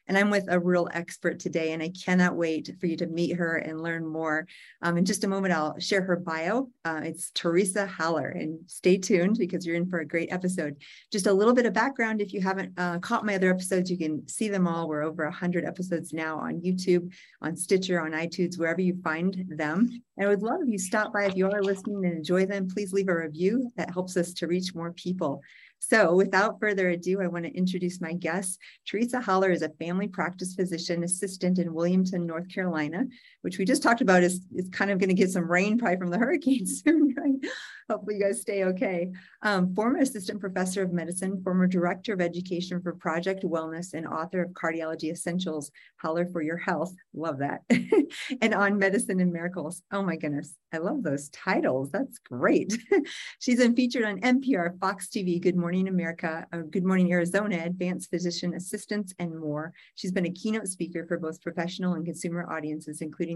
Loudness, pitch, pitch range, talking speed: -28 LUFS, 180 Hz, 170-200 Hz, 205 wpm